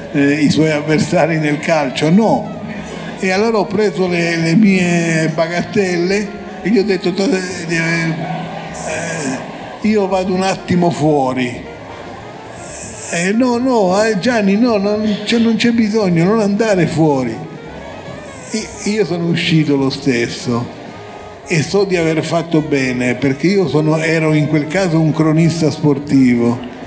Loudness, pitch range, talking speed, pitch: -15 LUFS, 155-205 Hz, 140 wpm, 175 Hz